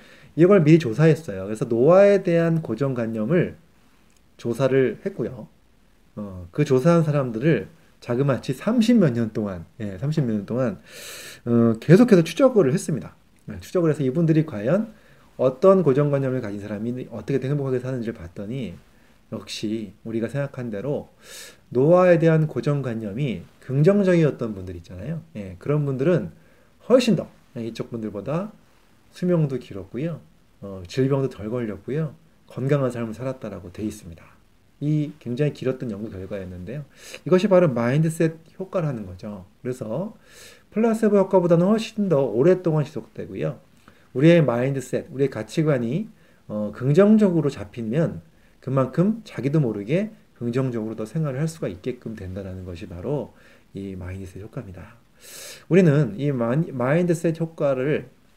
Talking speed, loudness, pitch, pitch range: 315 characters per minute, -22 LUFS, 135 Hz, 110-165 Hz